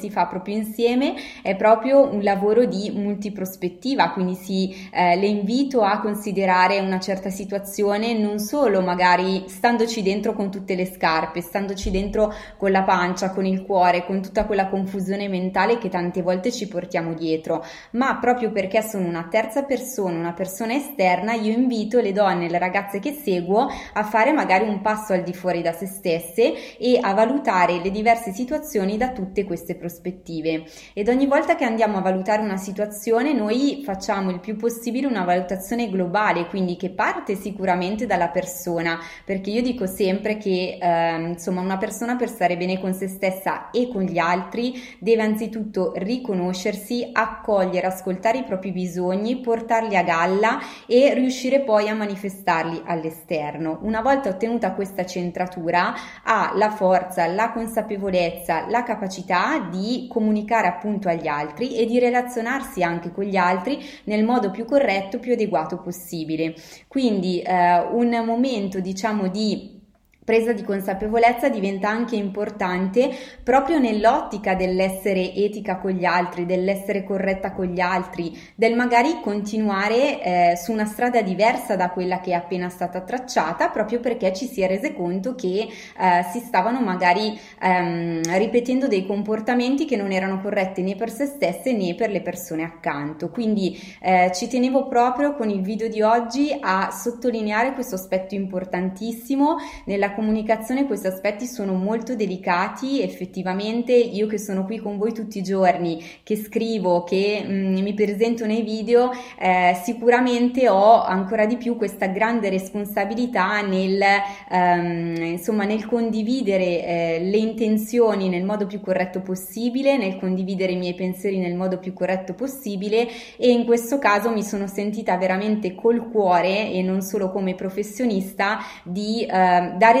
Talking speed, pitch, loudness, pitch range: 155 wpm, 200 Hz, -22 LUFS, 185-230 Hz